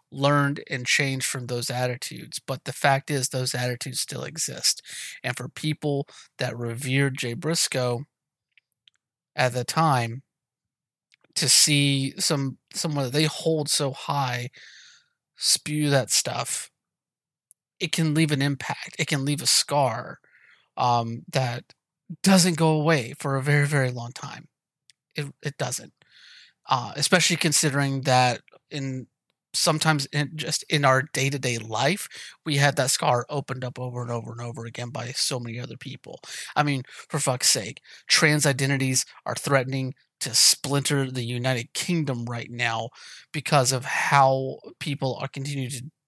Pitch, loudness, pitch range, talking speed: 135 Hz, -24 LUFS, 125-150 Hz, 150 wpm